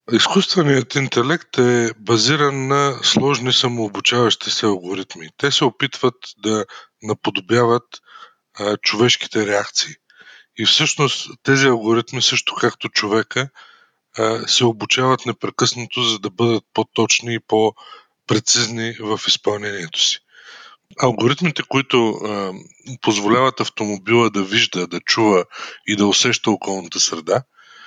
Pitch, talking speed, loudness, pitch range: 115 Hz, 110 wpm, -17 LUFS, 110-130 Hz